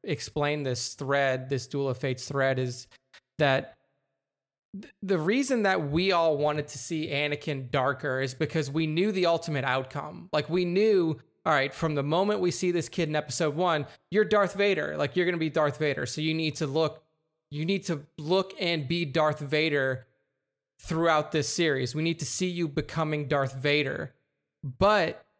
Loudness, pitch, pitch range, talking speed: -27 LUFS, 155 Hz, 140-170 Hz, 185 wpm